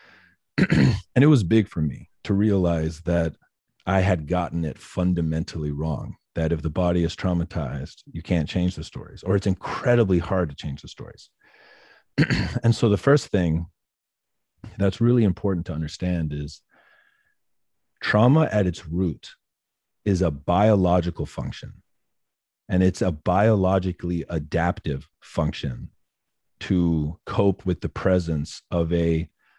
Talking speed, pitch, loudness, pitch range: 135 wpm, 90 Hz, -23 LUFS, 80-100 Hz